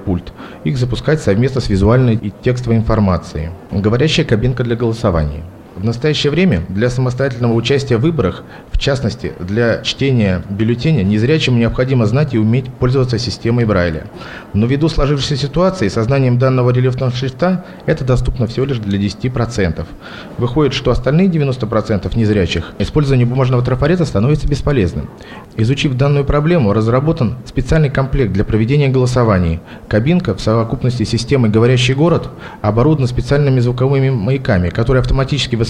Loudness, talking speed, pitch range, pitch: -15 LUFS, 135 wpm, 110-140 Hz, 125 Hz